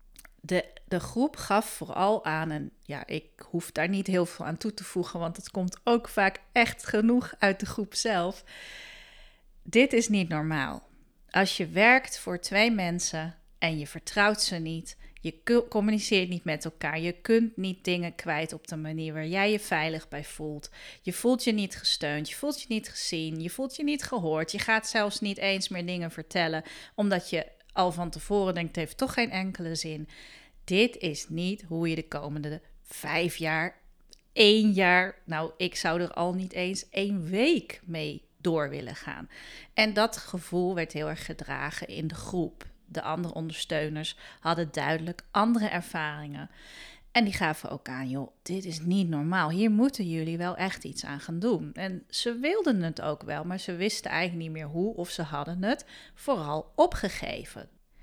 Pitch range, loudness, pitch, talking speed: 160-210 Hz, -29 LUFS, 180 Hz, 185 wpm